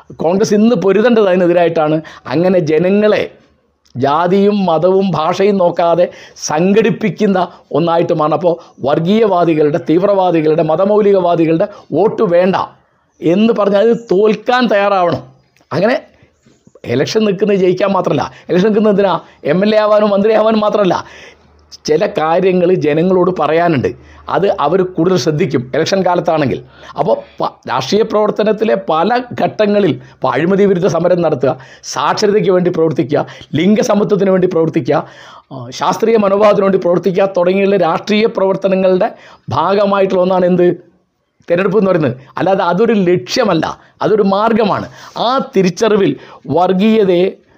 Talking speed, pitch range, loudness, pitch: 105 wpm, 165-205 Hz, -13 LUFS, 185 Hz